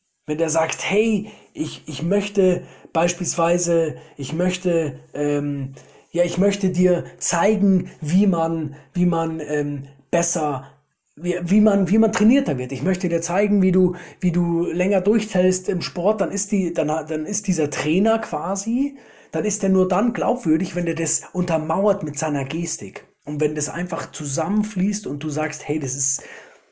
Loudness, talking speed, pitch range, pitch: -21 LUFS, 165 wpm, 155-195 Hz, 175 Hz